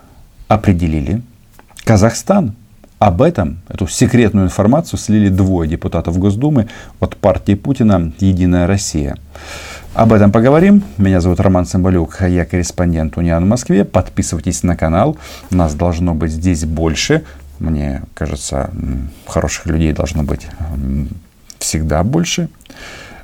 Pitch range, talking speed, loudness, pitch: 80-105 Hz, 120 wpm, -14 LUFS, 90 Hz